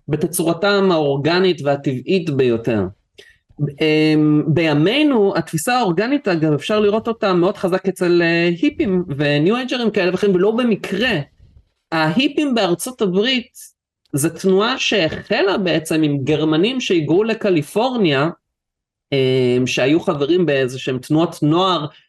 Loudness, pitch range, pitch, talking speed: -17 LUFS, 150-200 Hz, 175 Hz, 105 wpm